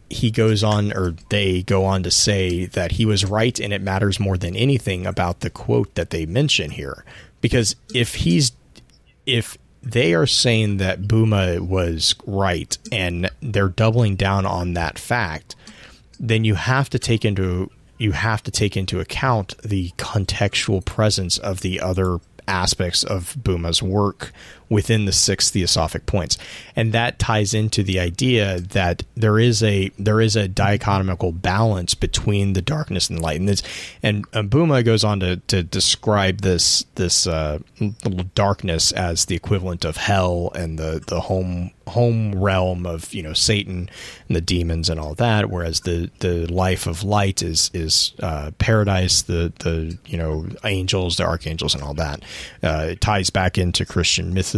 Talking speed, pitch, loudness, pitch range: 170 wpm, 95 Hz, -20 LUFS, 90-110 Hz